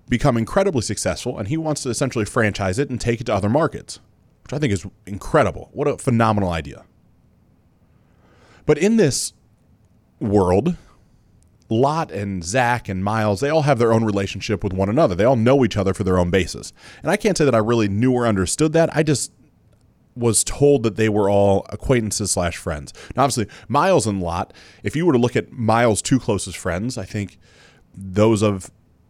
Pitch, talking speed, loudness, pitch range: 110 Hz, 190 wpm, -20 LUFS, 100-130 Hz